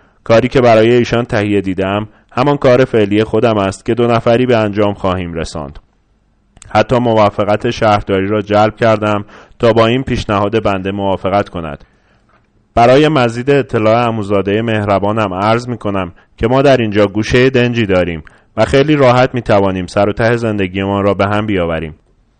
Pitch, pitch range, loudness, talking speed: 105 Hz, 100-115 Hz, -12 LUFS, 160 wpm